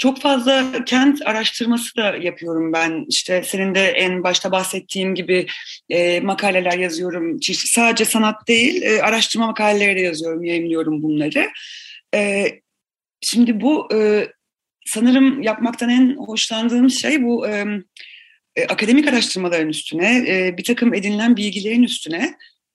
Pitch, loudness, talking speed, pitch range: 220 Hz, -17 LUFS, 110 wpm, 185-255 Hz